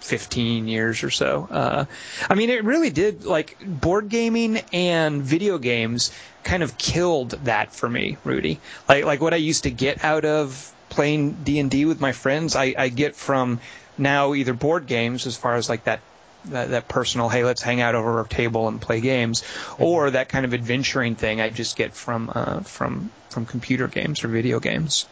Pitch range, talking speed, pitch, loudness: 115-155 Hz, 200 wpm, 130 Hz, -22 LUFS